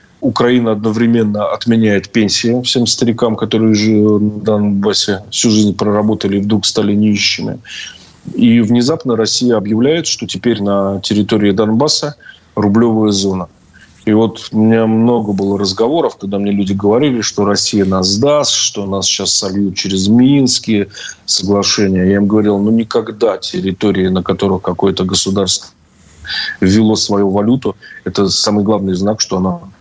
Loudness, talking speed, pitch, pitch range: -13 LUFS, 140 wpm, 105 Hz, 100-110 Hz